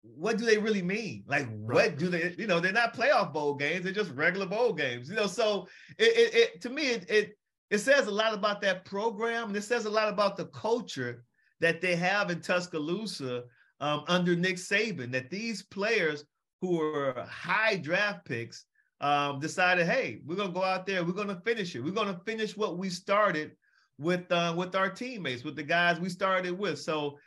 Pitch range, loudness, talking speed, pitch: 160-215 Hz, -29 LUFS, 205 wpm, 185 Hz